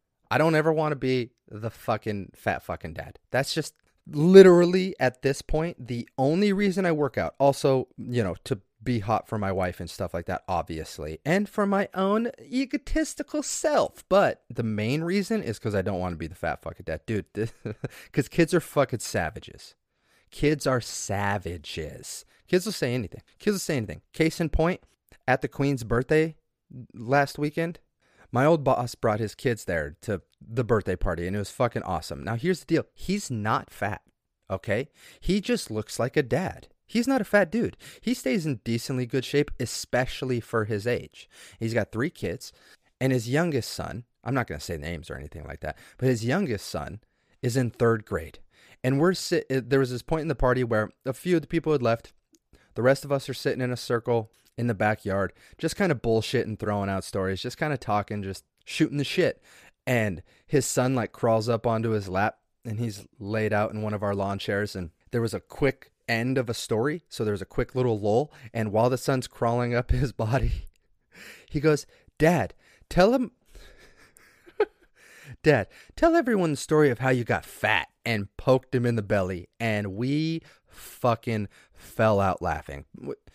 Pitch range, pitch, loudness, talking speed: 105-155 Hz, 125 Hz, -26 LUFS, 195 wpm